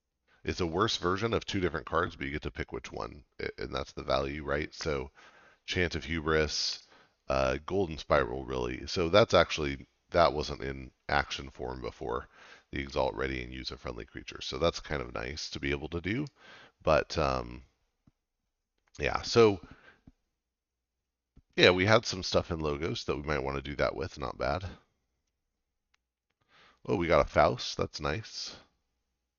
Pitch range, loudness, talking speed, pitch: 65-80 Hz, -31 LUFS, 165 wpm, 70 Hz